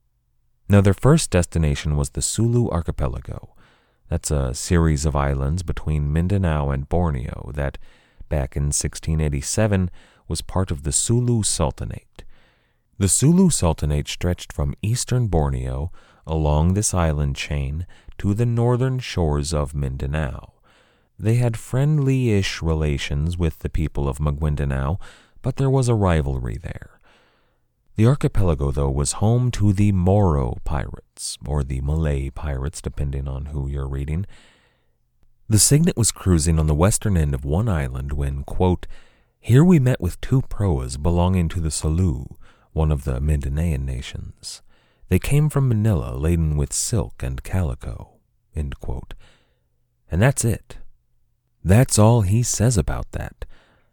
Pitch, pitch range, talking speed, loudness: 85 Hz, 70-105 Hz, 140 wpm, -21 LUFS